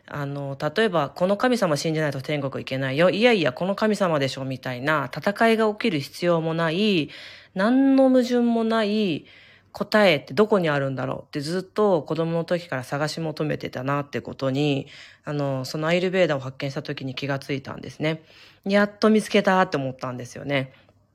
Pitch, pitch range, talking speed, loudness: 155 Hz, 140-200 Hz, 380 characters per minute, -23 LUFS